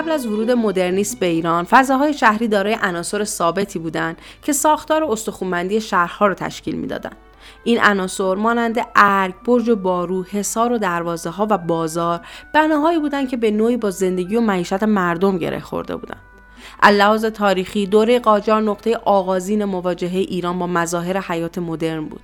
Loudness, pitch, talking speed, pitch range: -18 LUFS, 200 Hz, 155 wpm, 180-225 Hz